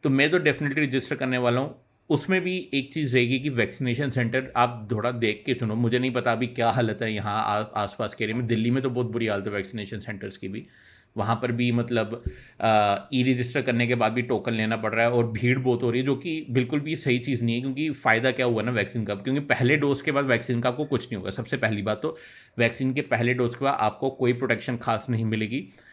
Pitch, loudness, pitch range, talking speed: 125 Hz, -25 LUFS, 115-130 Hz, 250 wpm